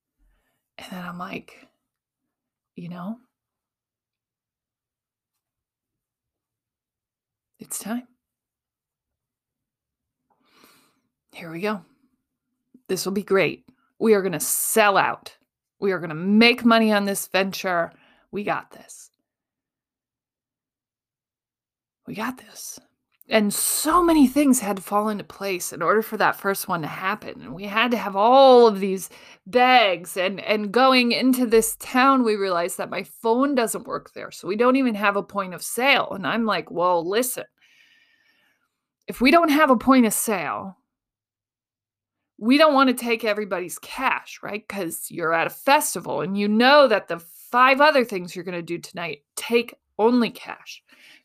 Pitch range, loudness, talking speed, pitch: 175-245 Hz, -20 LUFS, 150 wpm, 205 Hz